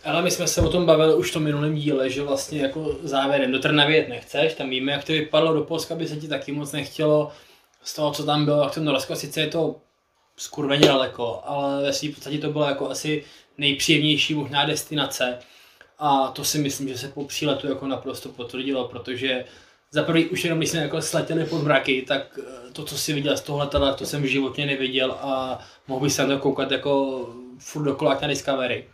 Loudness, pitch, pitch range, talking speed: -23 LUFS, 145 Hz, 135-150 Hz, 210 wpm